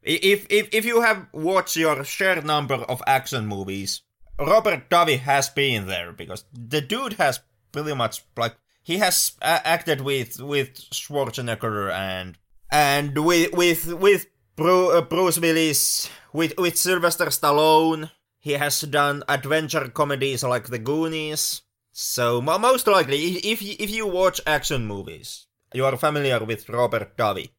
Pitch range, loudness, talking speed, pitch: 120-170 Hz, -22 LUFS, 140 wpm, 145 Hz